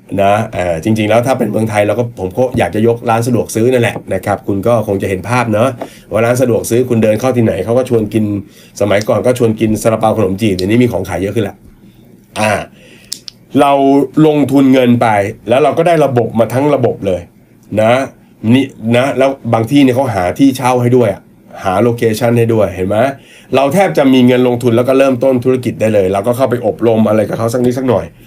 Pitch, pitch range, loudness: 115 Hz, 110-130 Hz, -12 LUFS